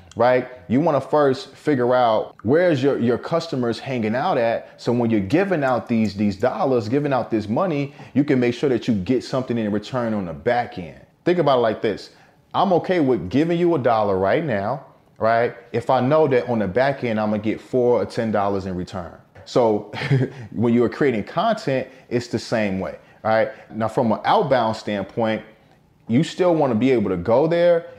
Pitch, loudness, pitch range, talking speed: 120 Hz, -21 LUFS, 110-135 Hz, 205 wpm